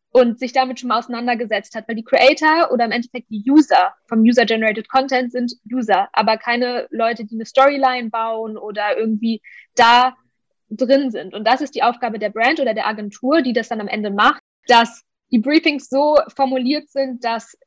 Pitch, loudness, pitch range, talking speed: 240 Hz, -17 LUFS, 225-260 Hz, 190 wpm